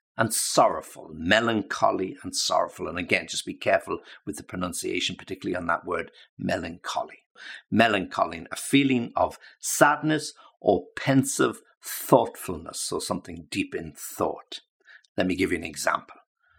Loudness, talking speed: -26 LUFS, 135 wpm